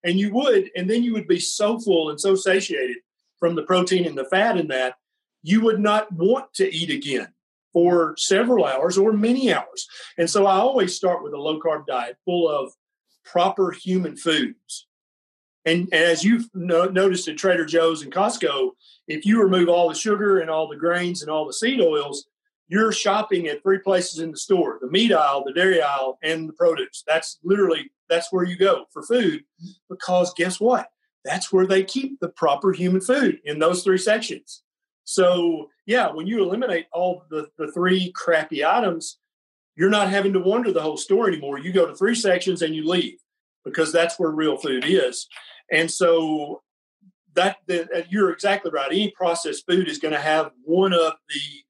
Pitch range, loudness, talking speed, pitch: 165-210 Hz, -21 LUFS, 190 wpm, 180 Hz